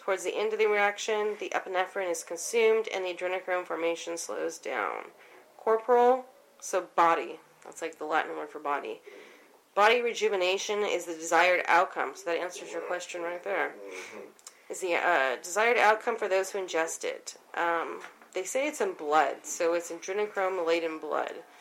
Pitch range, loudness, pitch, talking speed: 170-255 Hz, -29 LUFS, 190 Hz, 165 wpm